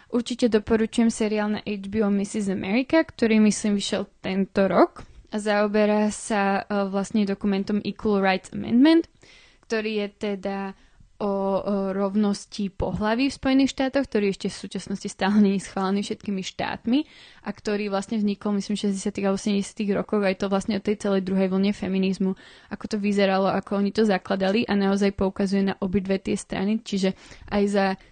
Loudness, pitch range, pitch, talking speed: -24 LUFS, 195-215 Hz, 205 Hz, 155 wpm